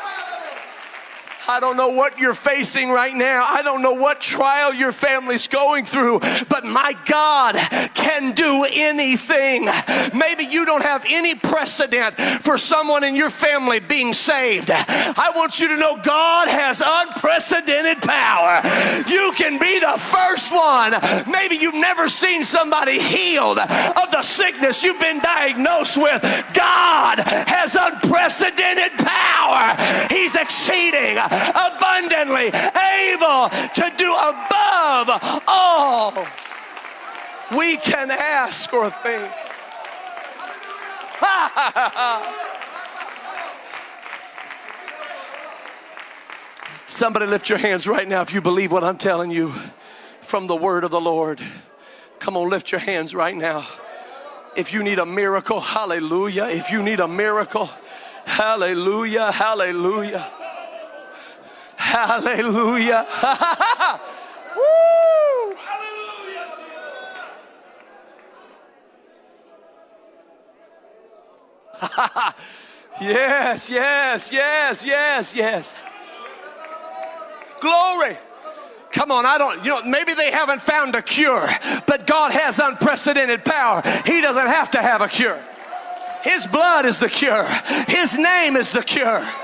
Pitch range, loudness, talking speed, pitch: 245-335 Hz, -17 LUFS, 110 wpm, 295 Hz